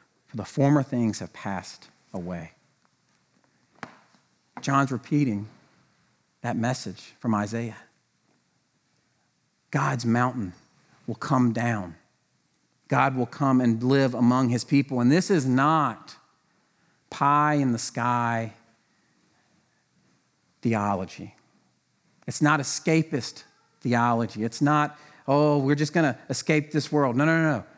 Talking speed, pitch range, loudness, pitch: 110 wpm, 115-145 Hz, -25 LUFS, 125 Hz